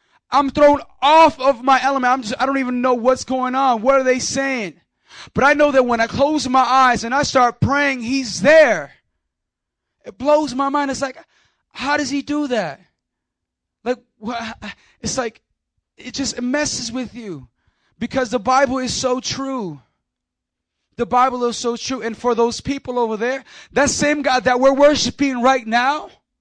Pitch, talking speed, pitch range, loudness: 255 Hz, 180 wpm, 240-275 Hz, -17 LUFS